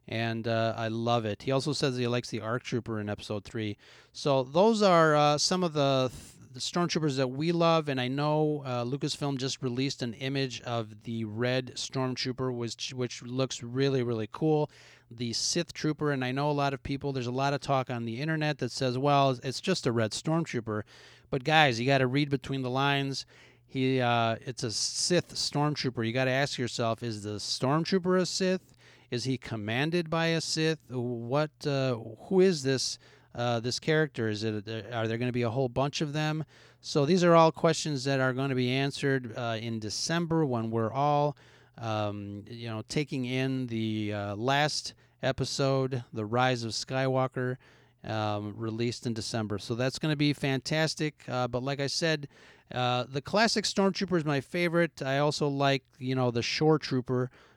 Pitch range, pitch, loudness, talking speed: 120-150 Hz, 130 Hz, -29 LUFS, 195 wpm